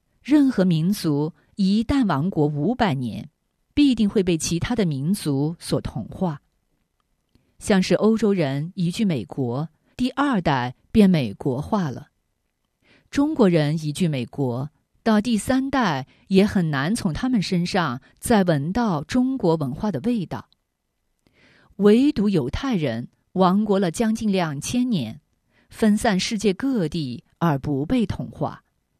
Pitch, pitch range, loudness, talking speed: 185 Hz, 150-220 Hz, -22 LUFS, 190 characters per minute